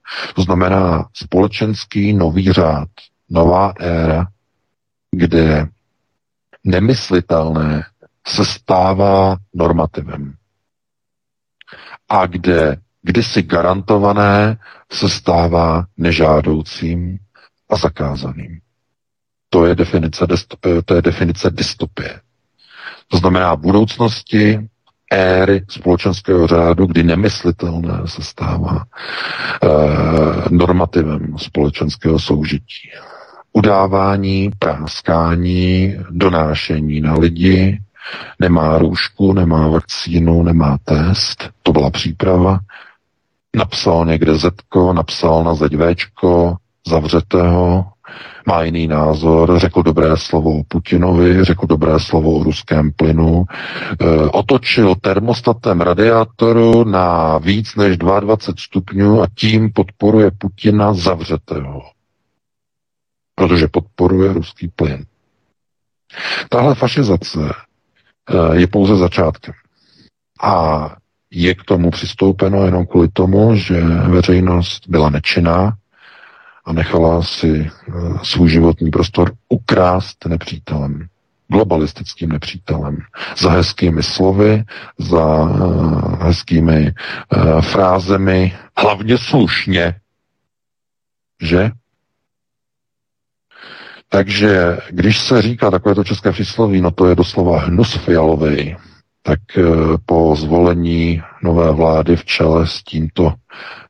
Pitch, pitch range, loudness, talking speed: 90 Hz, 80-100 Hz, -14 LUFS, 90 wpm